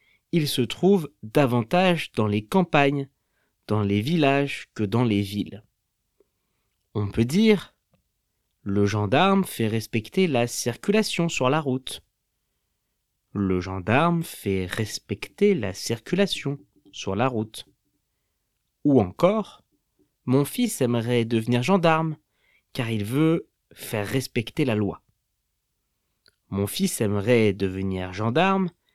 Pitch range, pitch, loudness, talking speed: 105-160 Hz, 125 Hz, -24 LUFS, 110 wpm